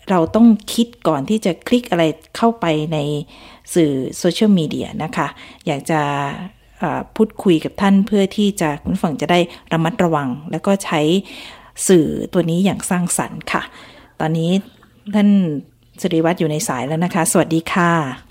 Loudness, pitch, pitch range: -18 LUFS, 175 Hz, 155-200 Hz